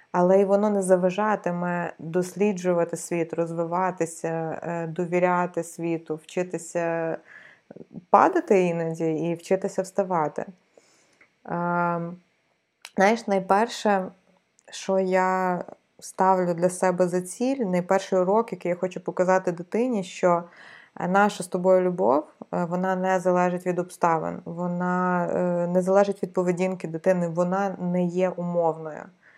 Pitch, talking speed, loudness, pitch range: 180 Hz, 105 wpm, -24 LUFS, 175-190 Hz